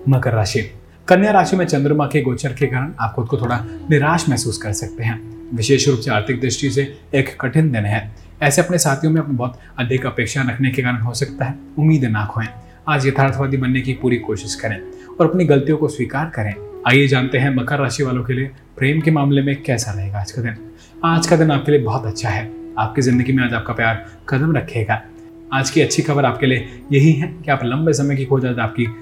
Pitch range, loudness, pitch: 115-145 Hz, -18 LUFS, 135 Hz